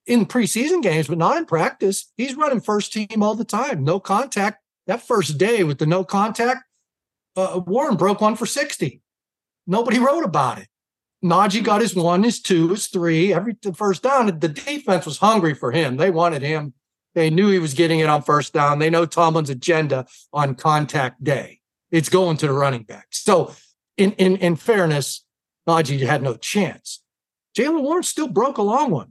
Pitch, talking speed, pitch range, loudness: 185 Hz, 190 wpm, 160-215 Hz, -20 LUFS